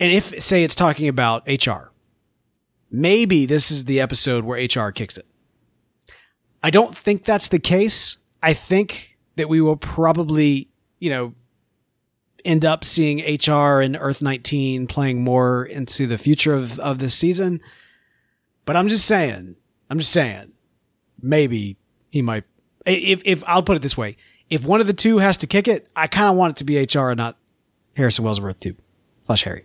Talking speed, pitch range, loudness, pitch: 180 wpm, 120-170 Hz, -18 LUFS, 145 Hz